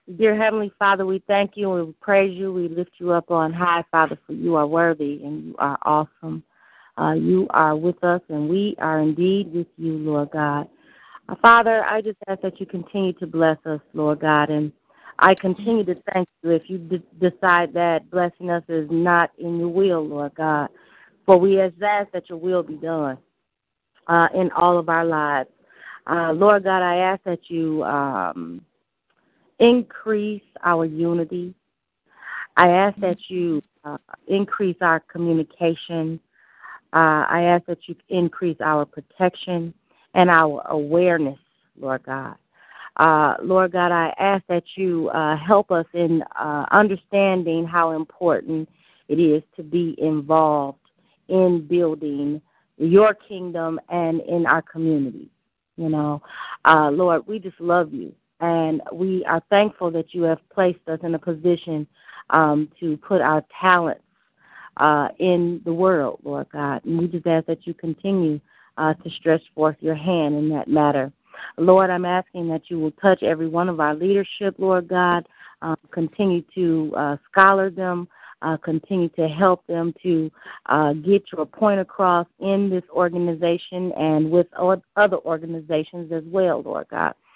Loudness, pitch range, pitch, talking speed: -20 LUFS, 155-185 Hz, 170 Hz, 160 wpm